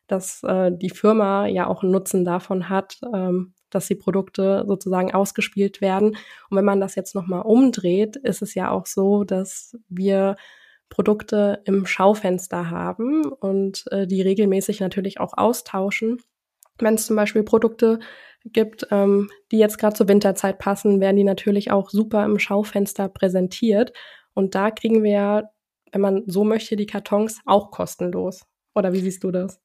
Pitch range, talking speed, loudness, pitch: 195-215 Hz, 160 wpm, -21 LUFS, 200 Hz